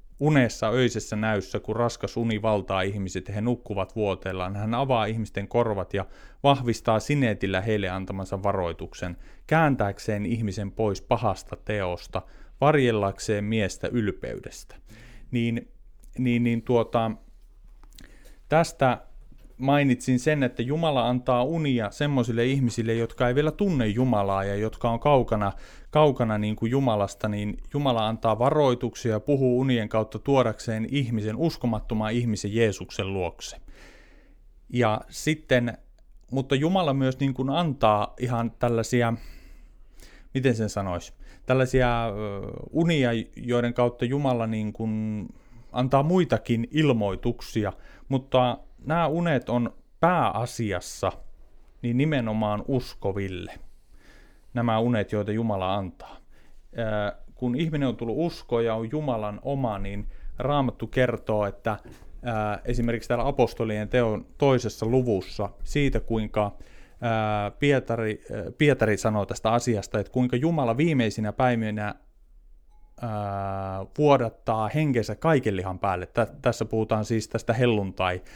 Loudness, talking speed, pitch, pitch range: -26 LUFS, 110 wpm, 115 Hz, 105-130 Hz